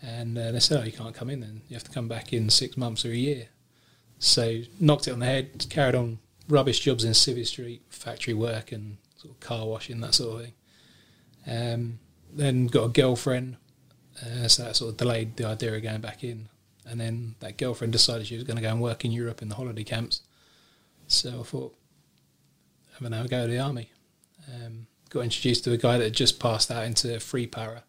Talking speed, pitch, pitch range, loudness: 225 wpm, 120 Hz, 115-125 Hz, -26 LUFS